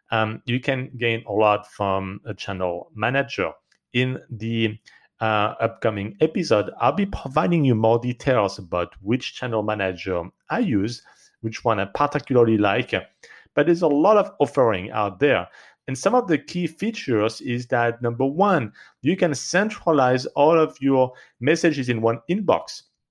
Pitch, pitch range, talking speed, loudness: 120 Hz, 105-145 Hz, 155 wpm, -22 LUFS